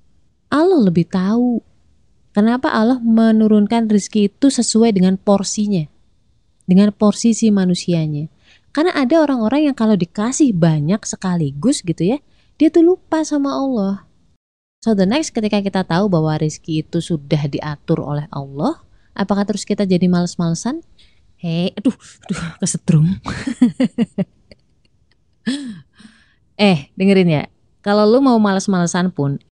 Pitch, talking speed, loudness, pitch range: 205 Hz, 120 wpm, -16 LUFS, 175-230 Hz